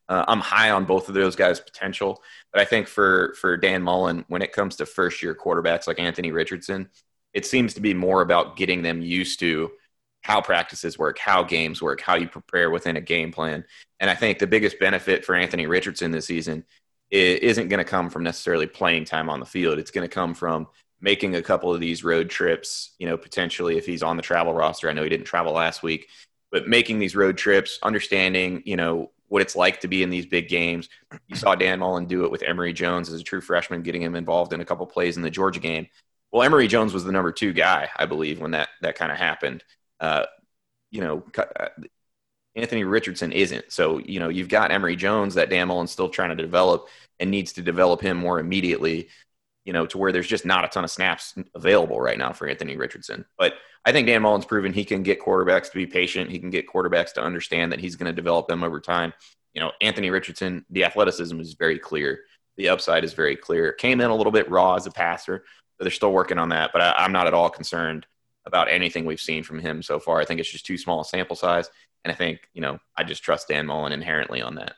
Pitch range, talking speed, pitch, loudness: 85-95 Hz, 235 wpm, 90 Hz, -23 LUFS